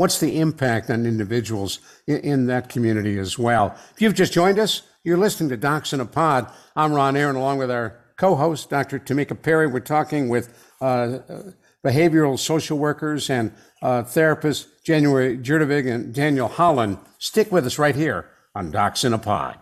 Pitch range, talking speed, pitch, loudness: 125-160 Hz, 175 wpm, 140 Hz, -21 LUFS